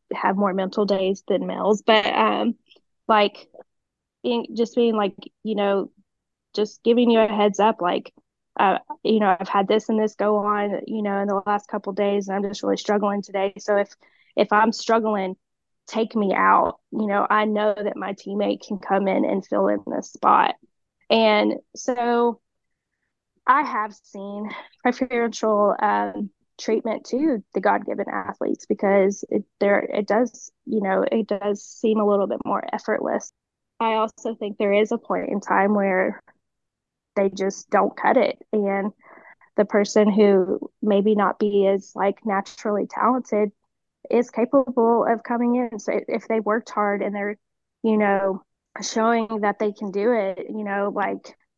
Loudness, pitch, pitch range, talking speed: -22 LUFS, 210 Hz, 200-225 Hz, 170 wpm